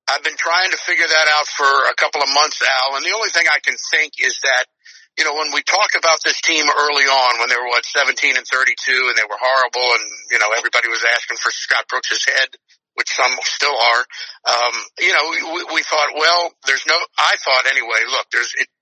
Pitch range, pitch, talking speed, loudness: 130-155 Hz, 145 Hz, 230 wpm, -15 LUFS